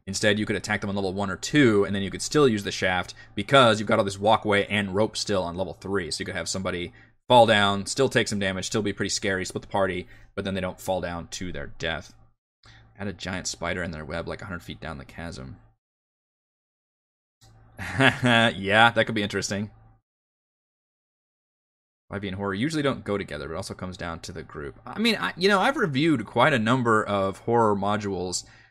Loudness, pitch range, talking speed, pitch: -24 LUFS, 95-110 Hz, 215 wpm, 100 Hz